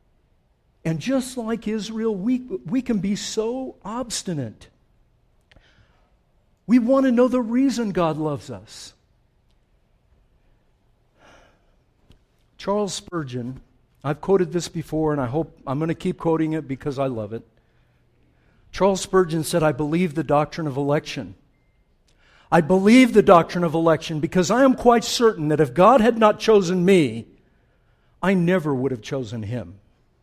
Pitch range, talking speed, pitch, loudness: 140-210 Hz, 140 wpm, 165 Hz, -21 LUFS